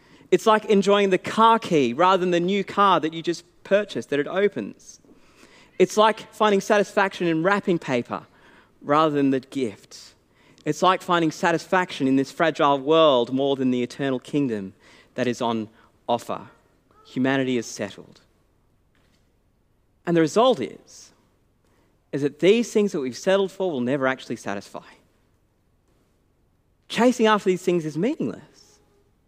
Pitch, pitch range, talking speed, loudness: 155 Hz, 125-195 Hz, 145 wpm, -22 LUFS